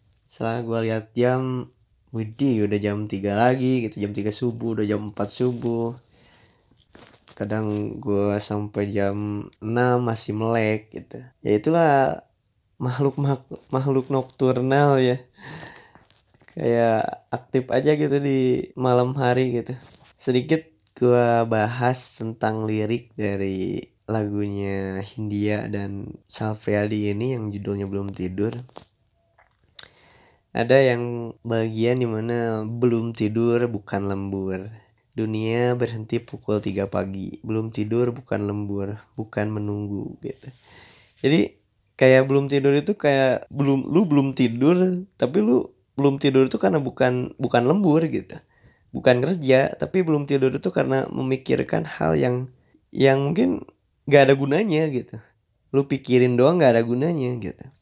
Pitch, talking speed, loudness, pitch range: 120 Hz, 120 wpm, -22 LUFS, 105-130 Hz